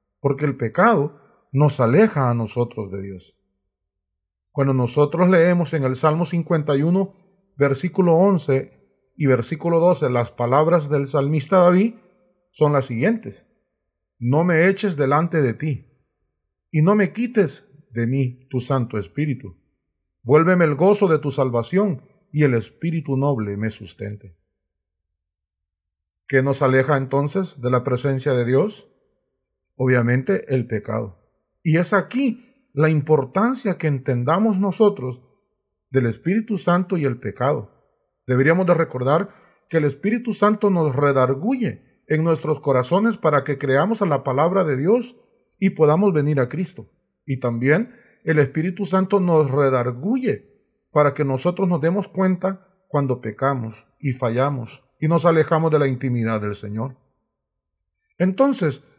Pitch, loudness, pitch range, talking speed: 145 Hz, -20 LUFS, 125-180 Hz, 135 wpm